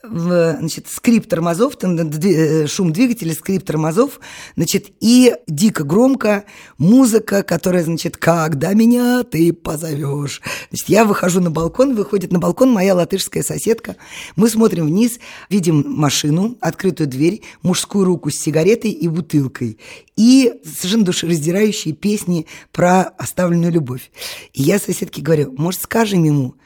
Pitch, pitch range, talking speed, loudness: 180 Hz, 160-210 Hz, 125 wpm, -16 LUFS